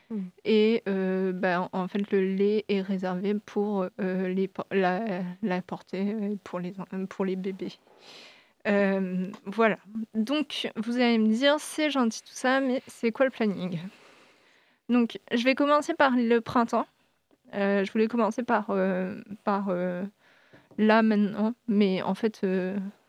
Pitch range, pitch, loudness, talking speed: 190-225 Hz, 205 Hz, -27 LUFS, 150 wpm